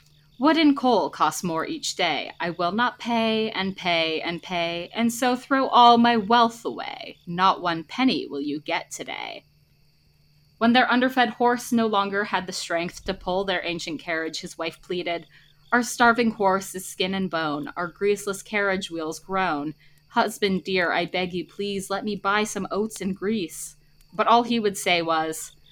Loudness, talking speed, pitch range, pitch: -24 LUFS, 180 wpm, 170-230 Hz, 190 Hz